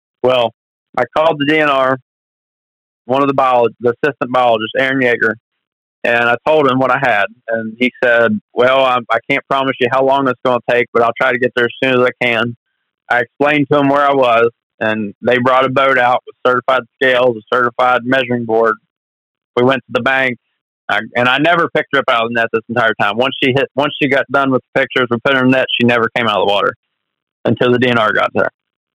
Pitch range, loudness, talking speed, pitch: 120-135 Hz, -14 LUFS, 235 wpm, 125 Hz